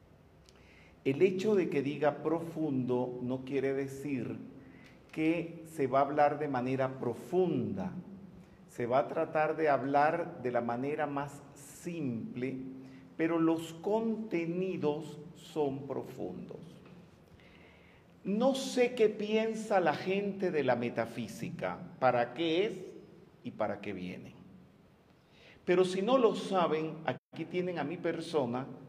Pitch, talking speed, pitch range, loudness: 155 Hz, 125 wpm, 130-180 Hz, -33 LUFS